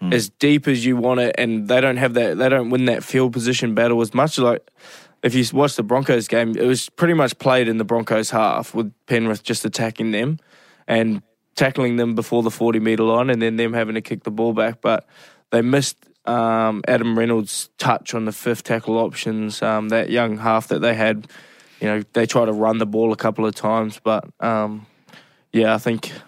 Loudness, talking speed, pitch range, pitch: -19 LUFS, 215 wpm, 110-125 Hz, 115 Hz